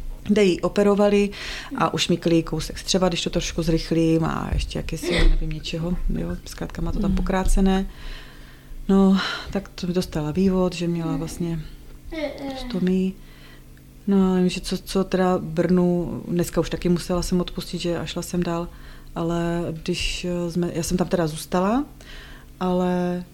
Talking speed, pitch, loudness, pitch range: 155 wpm, 175 Hz, -23 LUFS, 165-185 Hz